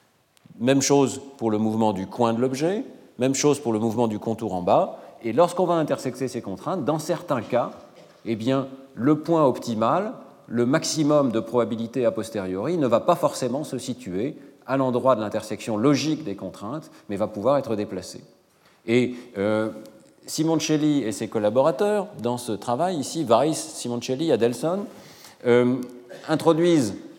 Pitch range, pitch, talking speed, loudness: 115-150 Hz, 125 Hz, 155 wpm, -24 LUFS